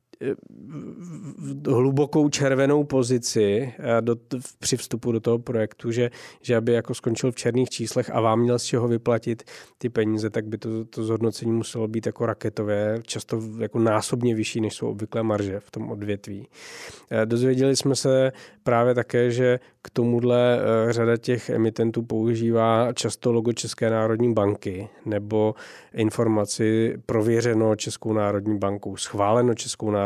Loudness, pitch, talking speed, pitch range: -24 LUFS, 115 Hz, 150 wpm, 110-120 Hz